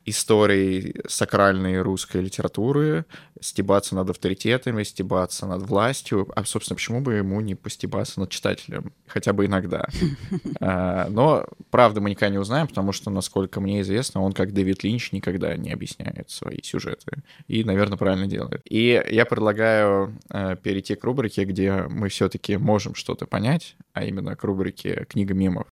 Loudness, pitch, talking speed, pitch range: -23 LUFS, 100 Hz, 150 wpm, 95-115 Hz